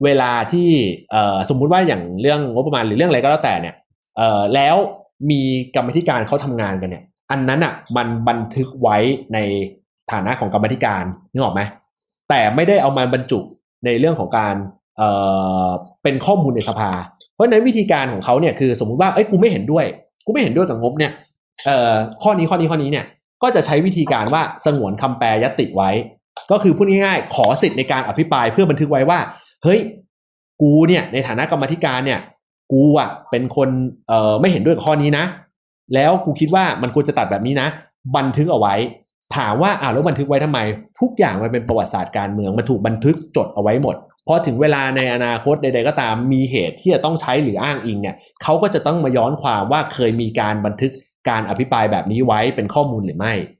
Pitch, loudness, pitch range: 135 Hz, -17 LUFS, 115-155 Hz